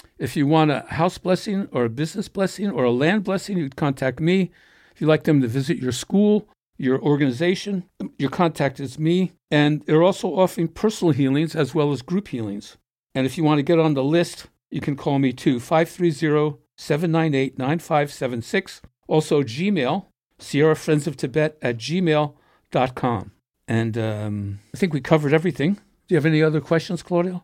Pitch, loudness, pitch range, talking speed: 155 Hz, -22 LUFS, 135-175 Hz, 175 wpm